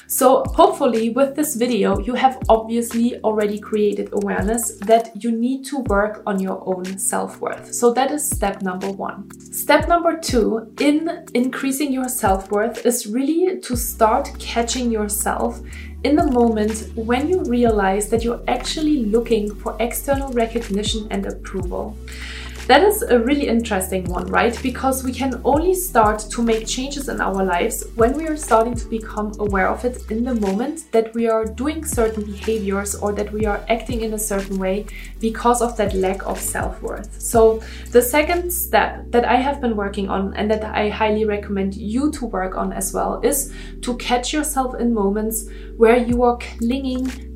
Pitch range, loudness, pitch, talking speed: 210-255 Hz, -20 LUFS, 230 Hz, 175 wpm